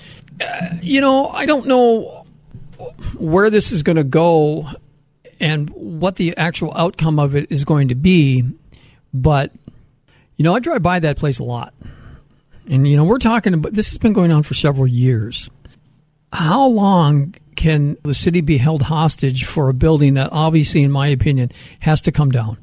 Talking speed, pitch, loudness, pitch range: 180 wpm, 155 Hz, -16 LUFS, 140-170 Hz